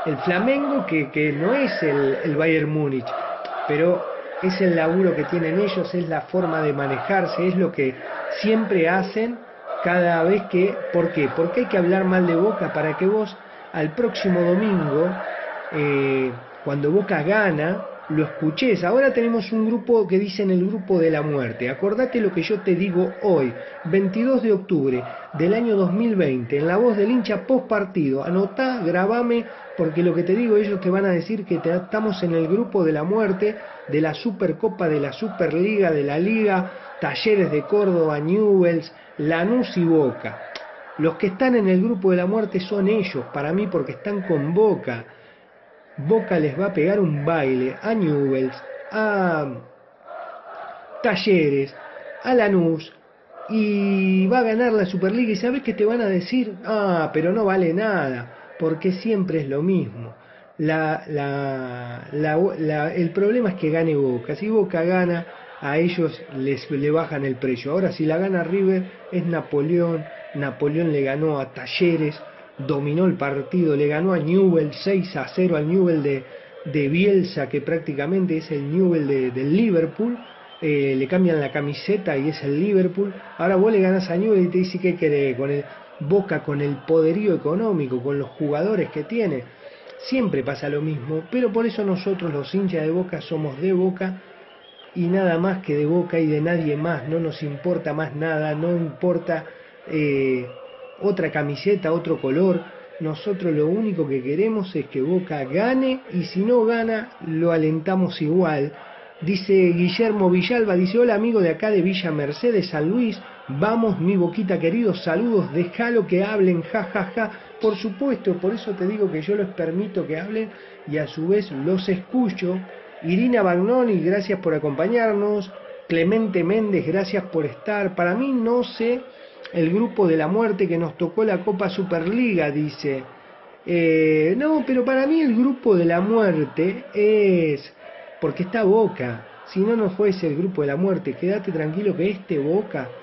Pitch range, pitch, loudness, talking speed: 155-205 Hz, 180 Hz, -21 LUFS, 170 wpm